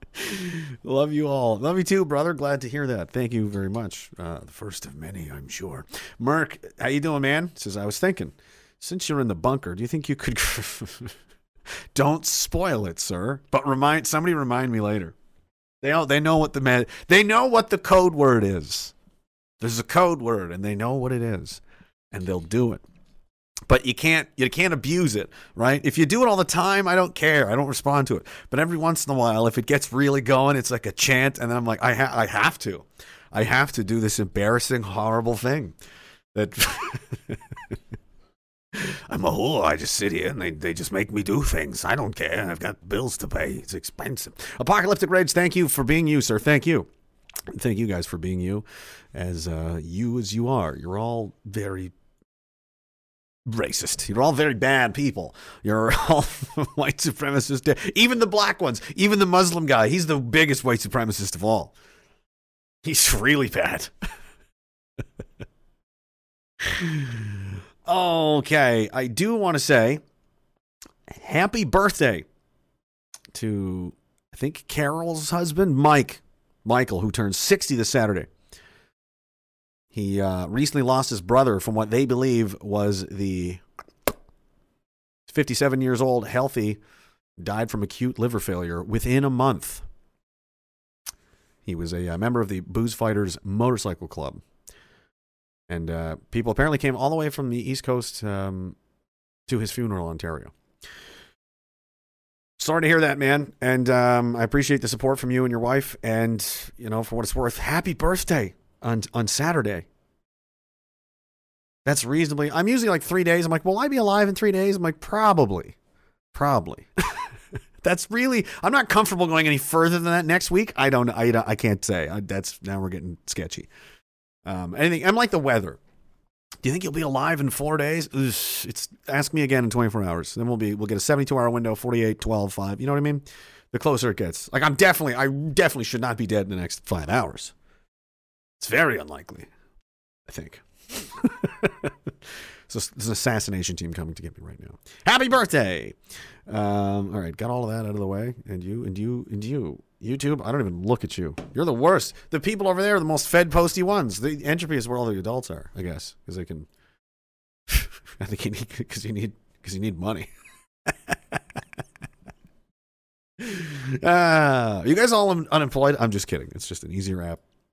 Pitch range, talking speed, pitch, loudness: 100-150 Hz, 180 wpm, 125 Hz, -23 LUFS